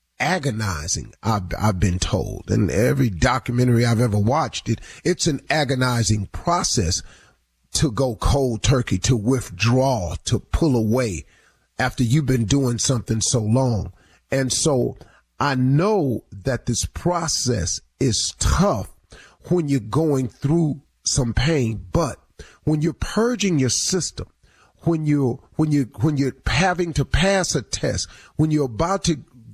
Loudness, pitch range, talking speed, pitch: -21 LUFS, 110-150 Hz, 140 wpm, 130 Hz